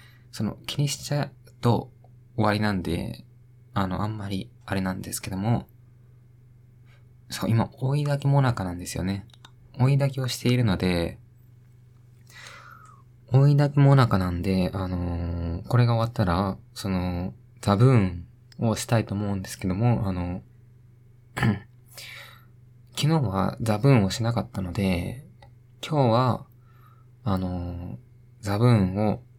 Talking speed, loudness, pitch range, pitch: 255 characters per minute, -25 LUFS, 100-125 Hz, 120 Hz